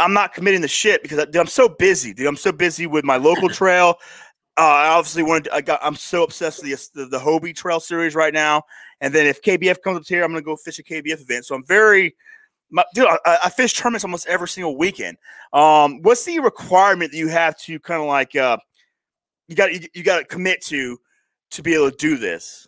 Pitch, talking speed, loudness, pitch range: 170 Hz, 240 wpm, -18 LUFS, 155-190 Hz